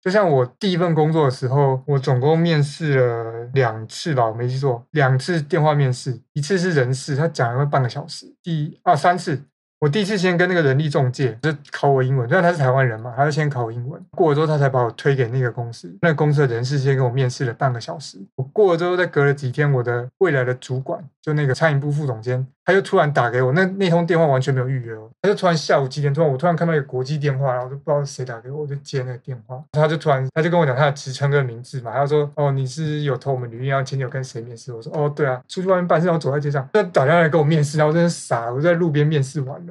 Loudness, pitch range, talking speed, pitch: -20 LUFS, 130-160 Hz, 410 characters per minute, 140 Hz